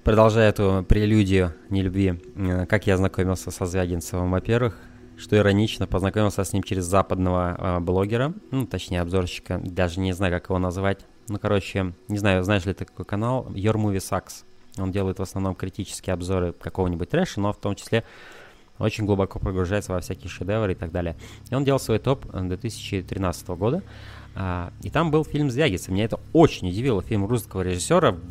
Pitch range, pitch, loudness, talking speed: 95-110 Hz, 95 Hz, -24 LUFS, 165 wpm